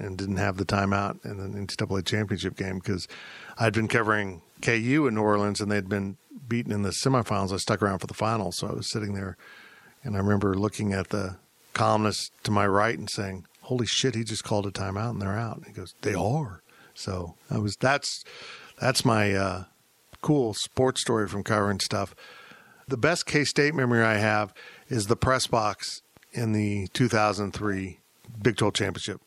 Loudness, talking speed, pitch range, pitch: -27 LUFS, 195 wpm, 100-115 Hz, 105 Hz